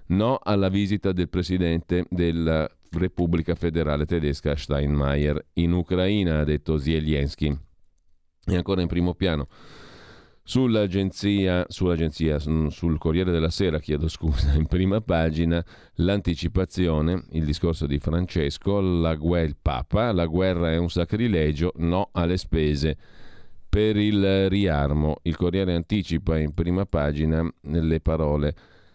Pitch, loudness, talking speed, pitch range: 85 Hz, -24 LUFS, 120 wpm, 80-90 Hz